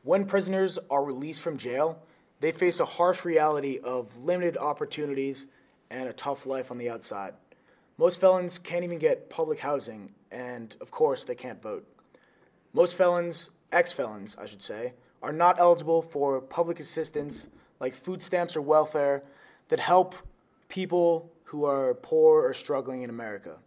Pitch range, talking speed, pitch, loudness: 140-185 Hz, 155 wpm, 165 Hz, -27 LUFS